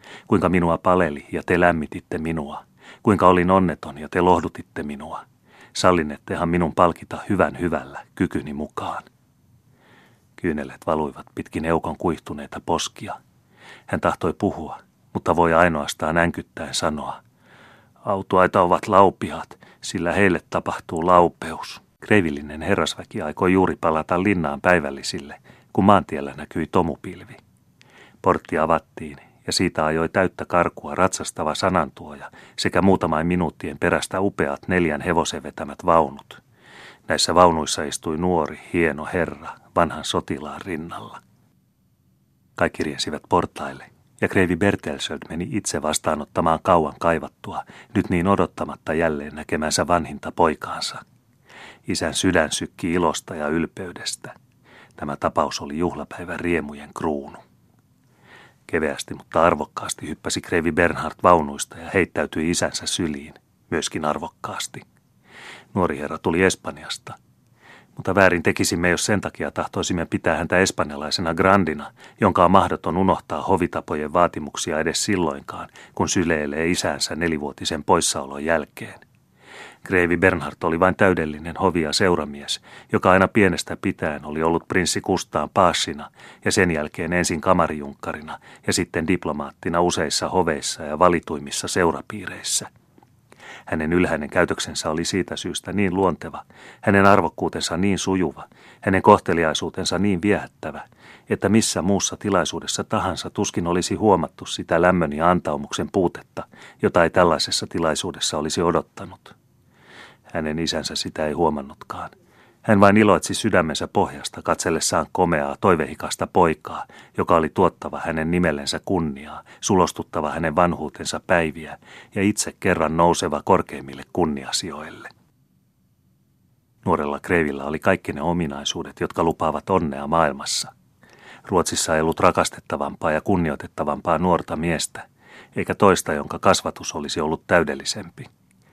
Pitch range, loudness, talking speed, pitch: 75-90 Hz, -21 LUFS, 115 wpm, 85 Hz